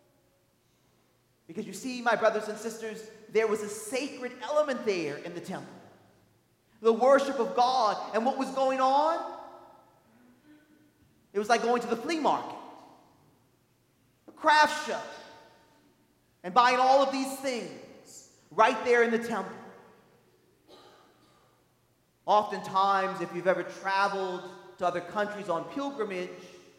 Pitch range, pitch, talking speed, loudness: 195-265 Hz, 225 Hz, 130 wpm, -28 LUFS